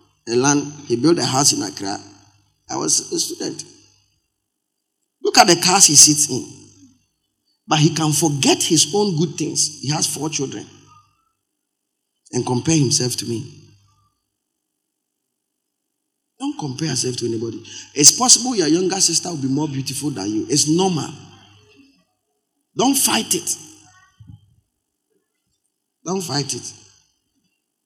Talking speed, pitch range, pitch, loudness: 130 wpm, 125-205 Hz, 155 Hz, -16 LUFS